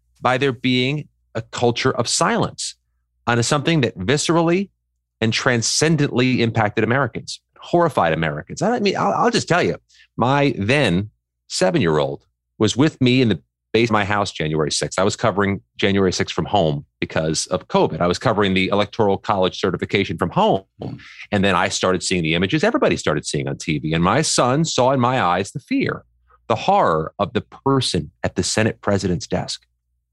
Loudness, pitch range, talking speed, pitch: -19 LUFS, 85-130 Hz, 180 wpm, 105 Hz